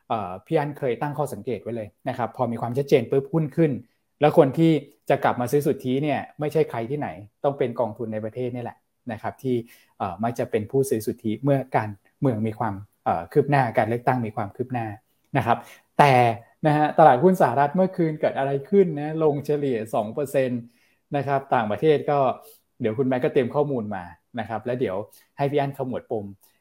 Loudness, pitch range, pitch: -24 LUFS, 115-145 Hz, 135 Hz